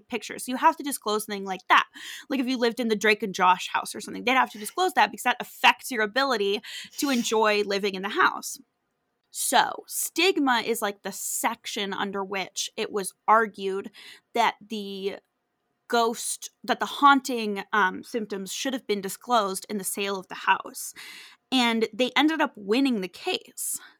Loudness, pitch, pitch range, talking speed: -25 LUFS, 220 Hz, 200-255 Hz, 185 wpm